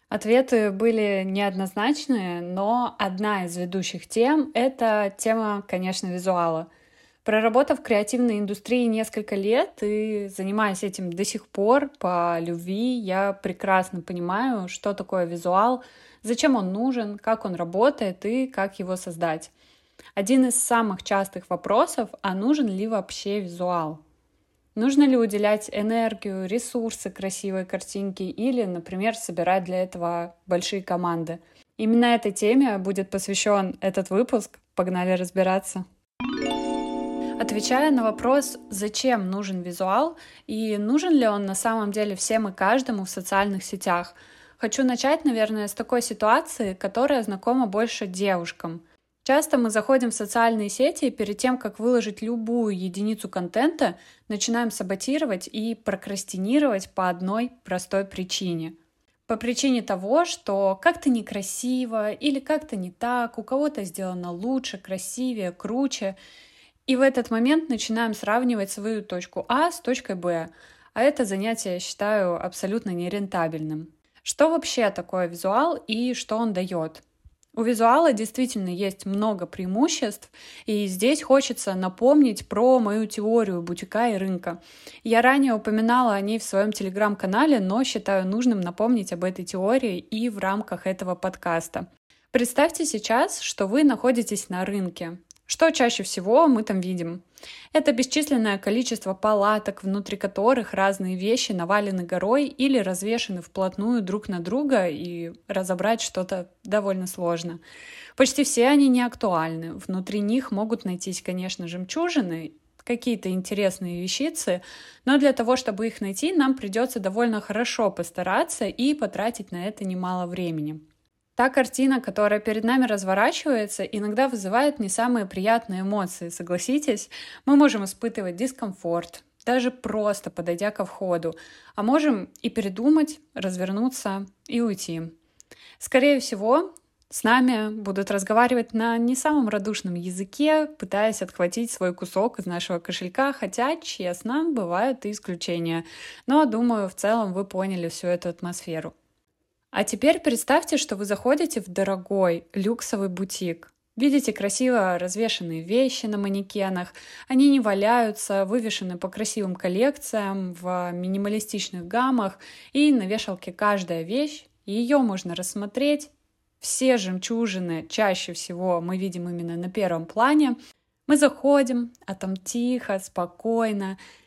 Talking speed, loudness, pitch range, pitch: 130 wpm, -24 LUFS, 190-245 Hz, 210 Hz